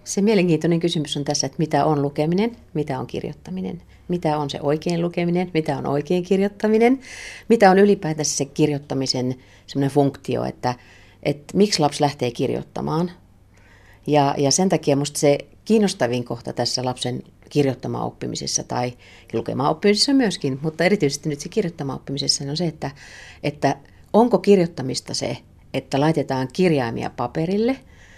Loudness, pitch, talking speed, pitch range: -21 LUFS, 150 Hz, 145 wpm, 130-175 Hz